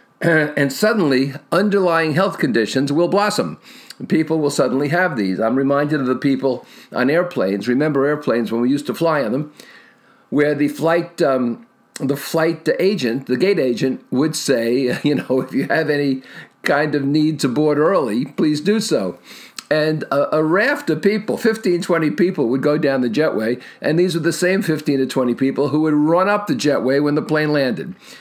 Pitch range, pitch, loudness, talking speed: 135-170 Hz, 150 Hz, -18 LUFS, 185 wpm